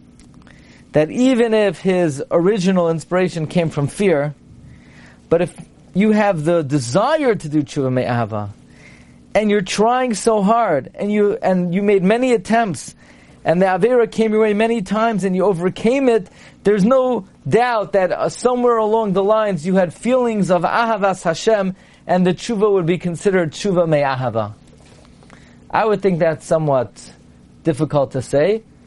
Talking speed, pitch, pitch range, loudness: 155 wpm, 190 Hz, 155-220 Hz, -17 LUFS